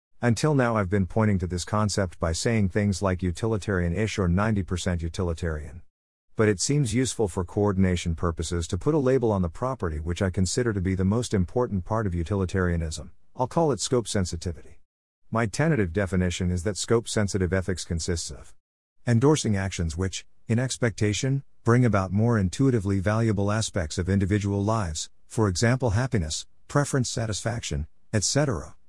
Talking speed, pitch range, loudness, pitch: 160 wpm, 90-115 Hz, -26 LUFS, 100 Hz